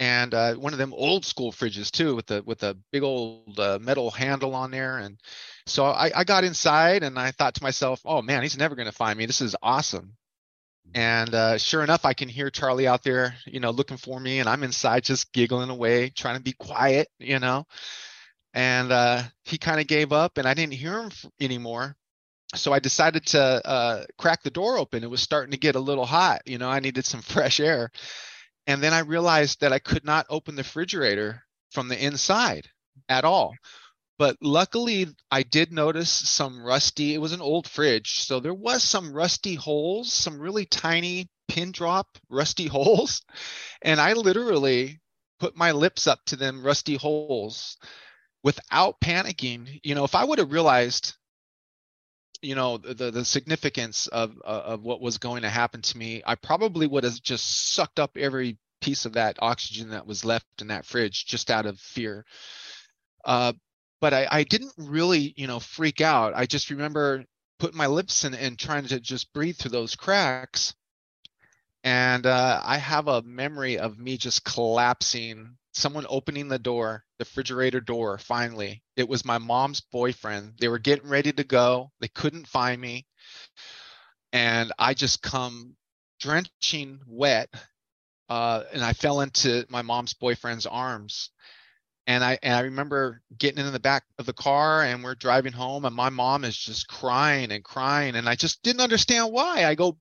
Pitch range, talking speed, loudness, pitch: 120-150 Hz, 185 wpm, -24 LUFS, 130 Hz